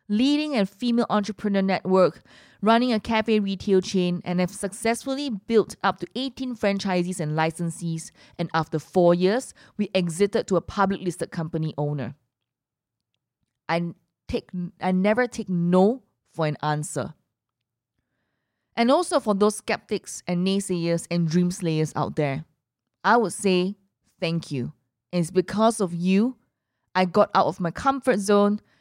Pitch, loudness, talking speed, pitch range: 180 Hz, -24 LUFS, 145 wpm, 160-210 Hz